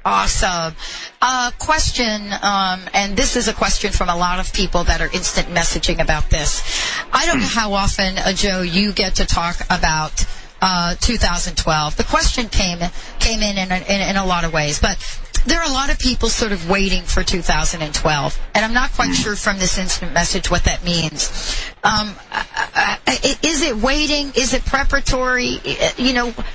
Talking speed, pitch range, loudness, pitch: 190 wpm, 180-250 Hz, -18 LUFS, 200 Hz